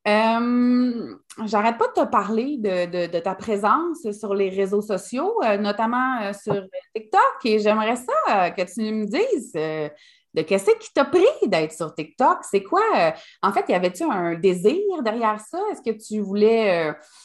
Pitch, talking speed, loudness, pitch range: 215 Hz, 185 wpm, -22 LUFS, 195-270 Hz